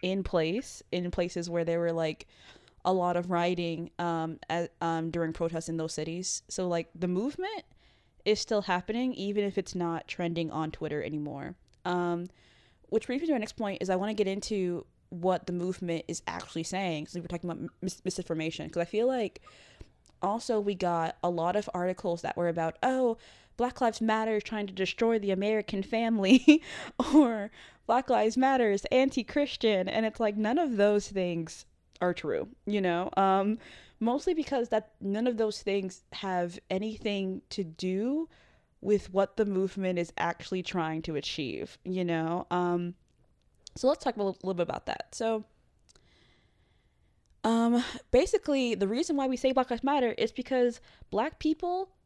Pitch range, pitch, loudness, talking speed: 175-225 Hz, 195 Hz, -30 LUFS, 175 wpm